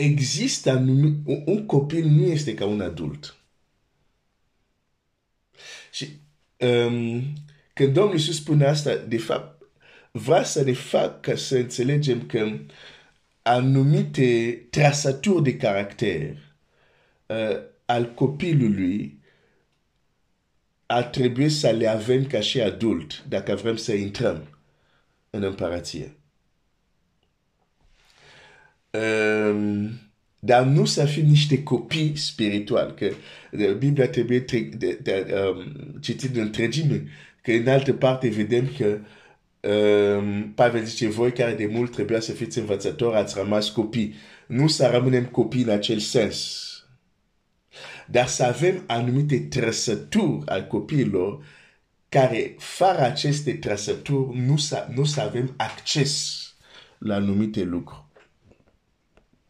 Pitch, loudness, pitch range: 120 Hz, -23 LUFS, 105-140 Hz